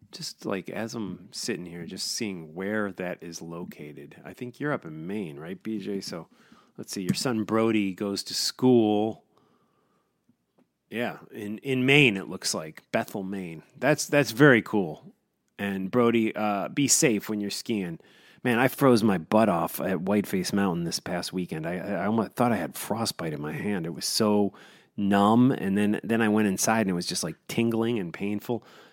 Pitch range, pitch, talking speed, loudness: 95-120 Hz, 105 Hz, 185 wpm, -26 LUFS